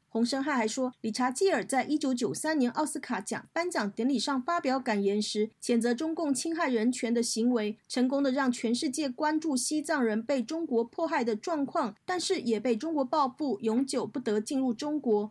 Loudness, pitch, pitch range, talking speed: -30 LUFS, 260 Hz, 230-305 Hz, 300 characters per minute